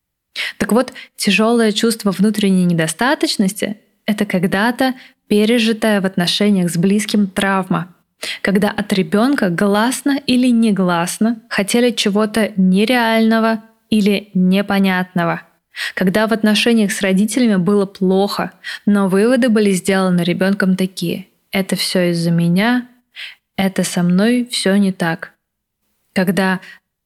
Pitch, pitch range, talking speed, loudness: 205 Hz, 190-225 Hz, 110 wpm, -16 LUFS